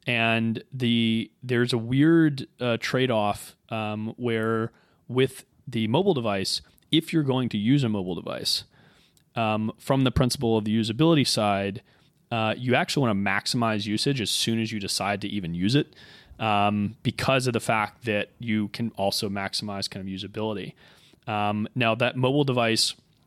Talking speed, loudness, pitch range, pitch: 165 wpm, -25 LUFS, 105-125 Hz, 115 Hz